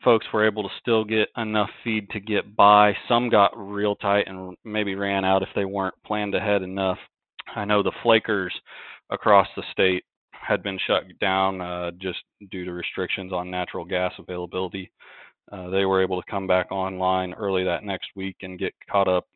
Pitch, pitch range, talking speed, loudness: 95 Hz, 95-105 Hz, 190 wpm, -24 LUFS